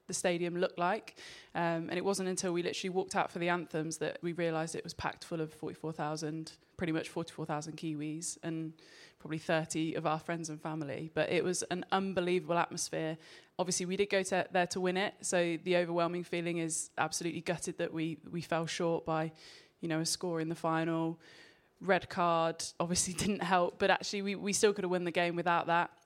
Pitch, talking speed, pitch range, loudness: 170 Hz, 205 wpm, 160-180 Hz, -34 LUFS